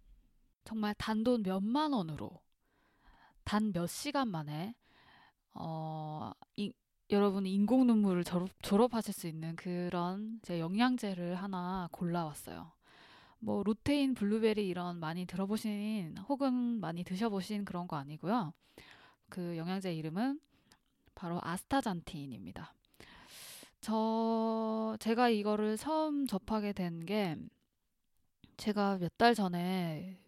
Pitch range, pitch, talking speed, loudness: 175-225 Hz, 200 Hz, 225 characters per minute, -35 LUFS